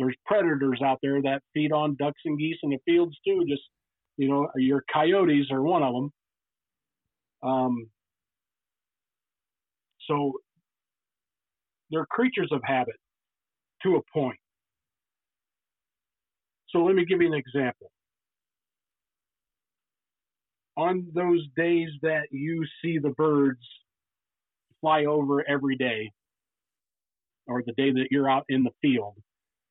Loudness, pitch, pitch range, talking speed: -26 LUFS, 140 Hz, 130-160 Hz, 120 wpm